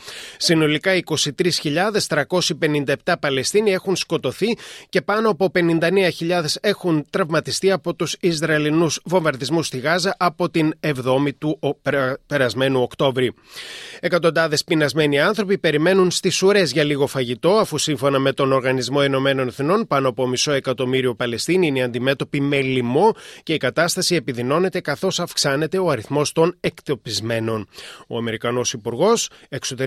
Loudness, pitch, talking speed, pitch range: -20 LUFS, 155 Hz, 125 wpm, 135-180 Hz